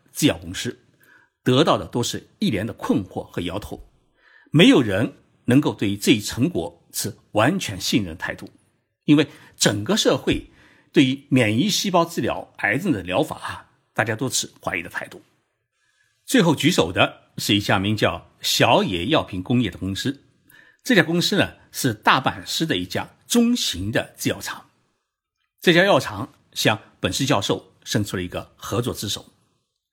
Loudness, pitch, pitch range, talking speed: -21 LUFS, 125 Hz, 100-155 Hz, 240 characters per minute